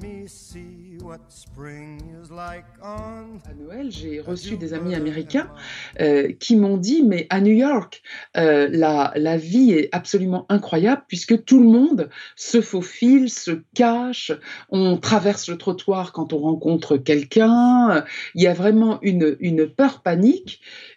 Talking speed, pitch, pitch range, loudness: 120 wpm, 185 Hz, 160-225 Hz, -19 LUFS